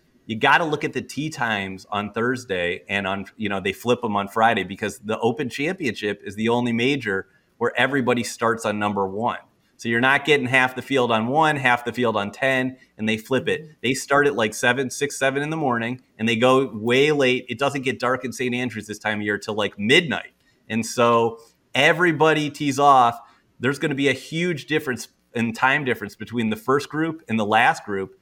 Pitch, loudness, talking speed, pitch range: 120 Hz, -22 LUFS, 220 wpm, 110-135 Hz